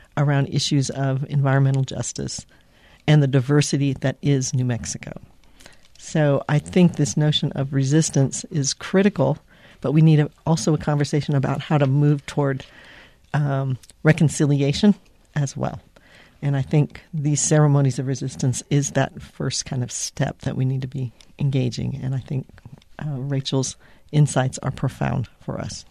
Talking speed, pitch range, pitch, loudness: 155 wpm, 135-150 Hz, 140 Hz, -22 LUFS